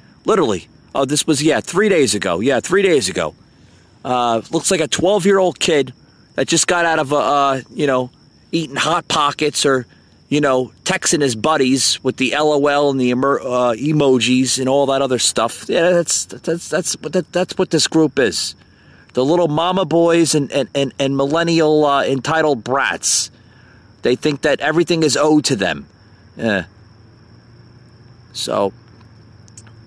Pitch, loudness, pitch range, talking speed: 140 Hz, -16 LUFS, 120-160 Hz, 165 wpm